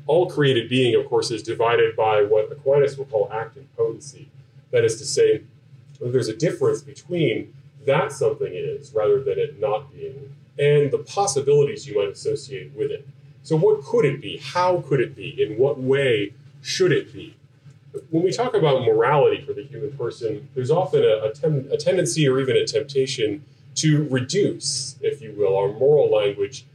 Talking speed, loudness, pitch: 185 wpm, -21 LUFS, 175 Hz